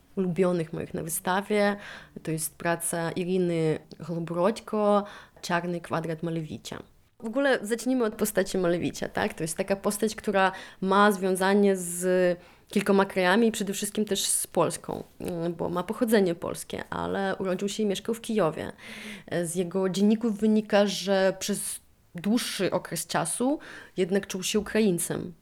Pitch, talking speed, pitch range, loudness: 190 Hz, 140 wpm, 175-210 Hz, -27 LUFS